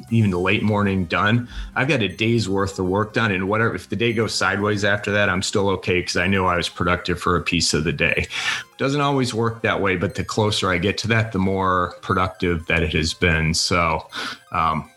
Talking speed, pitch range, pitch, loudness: 235 wpm, 90-110 Hz, 95 Hz, -20 LUFS